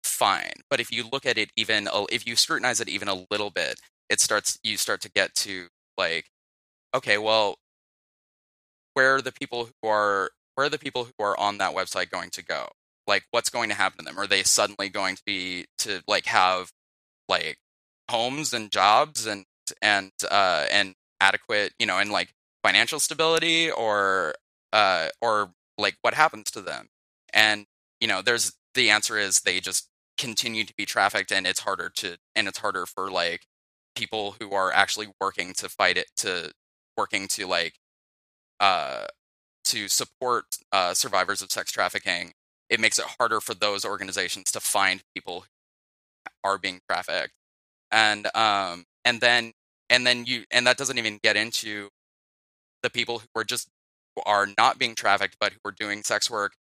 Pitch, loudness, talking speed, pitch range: 105 Hz, -24 LUFS, 180 wpm, 95-120 Hz